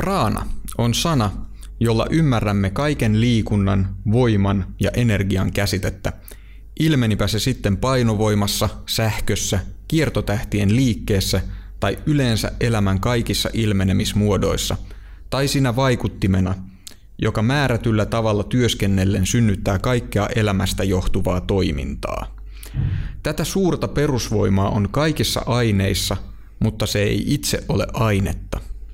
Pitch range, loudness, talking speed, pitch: 95-120 Hz, -20 LUFS, 95 wpm, 105 Hz